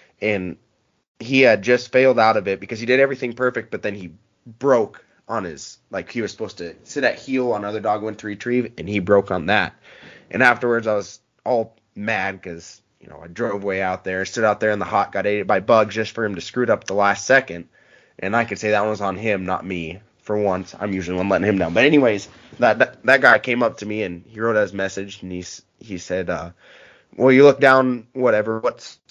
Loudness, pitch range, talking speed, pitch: -19 LUFS, 95-115 Hz, 235 wpm, 105 Hz